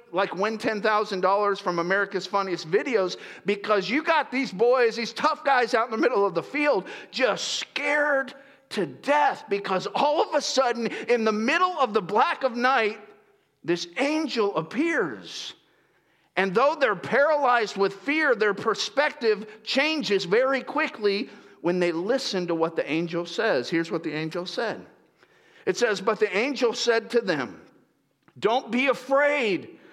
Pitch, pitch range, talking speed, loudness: 230 Hz, 200-280 Hz, 155 wpm, -24 LUFS